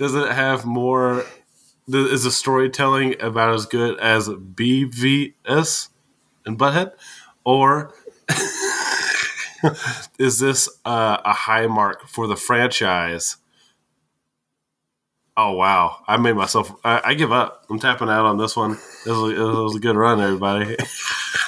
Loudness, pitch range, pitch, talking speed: -19 LUFS, 110-135 Hz, 125 Hz, 135 wpm